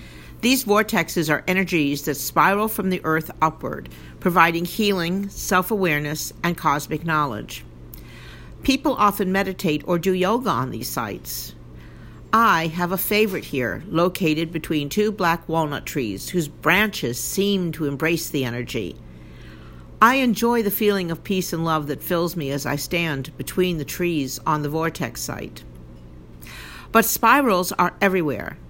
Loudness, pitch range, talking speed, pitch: -21 LUFS, 135-190 Hz, 145 wpm, 165 Hz